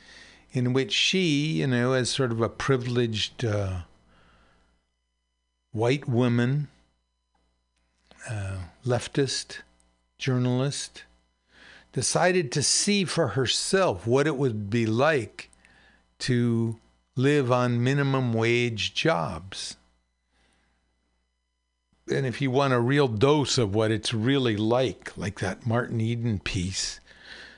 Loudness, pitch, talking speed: -25 LUFS, 115 Hz, 105 wpm